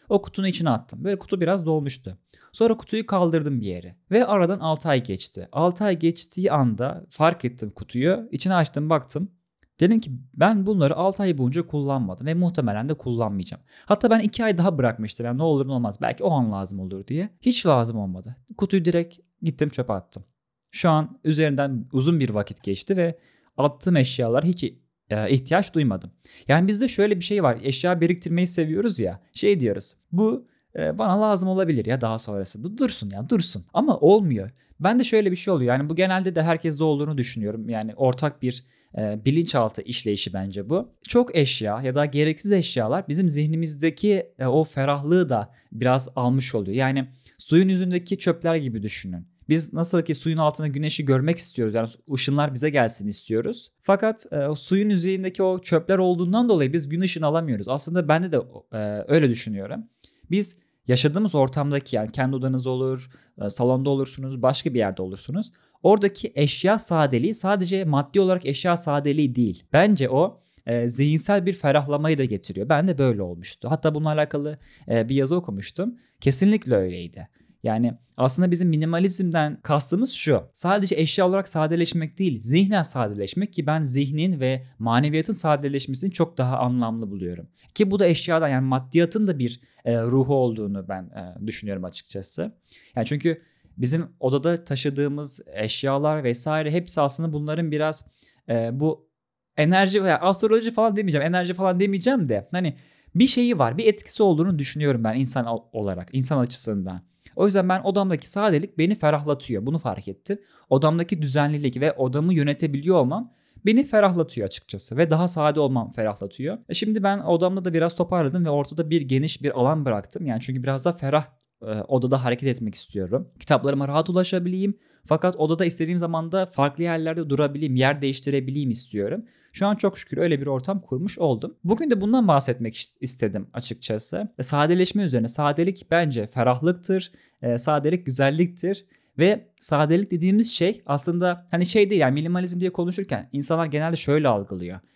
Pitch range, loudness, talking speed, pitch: 125-180 Hz, -23 LUFS, 160 wpm, 150 Hz